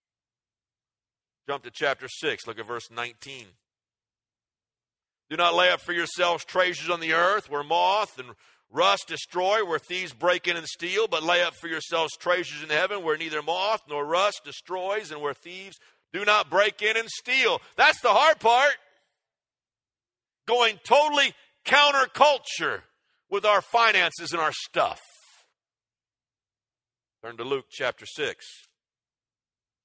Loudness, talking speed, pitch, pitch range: -24 LUFS, 140 wpm, 170 Hz, 135-205 Hz